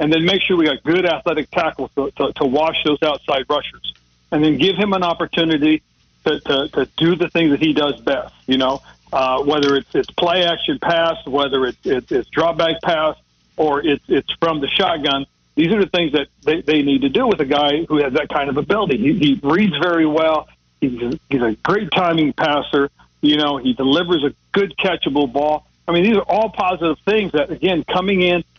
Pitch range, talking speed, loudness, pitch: 140-175 Hz, 215 wpm, -17 LUFS, 155 Hz